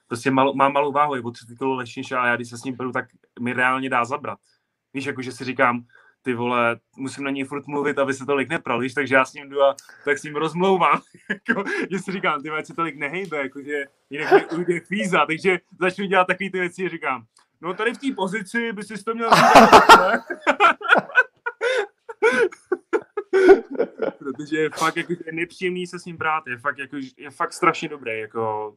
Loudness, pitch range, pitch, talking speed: -21 LUFS, 135-190 Hz, 150 Hz, 200 wpm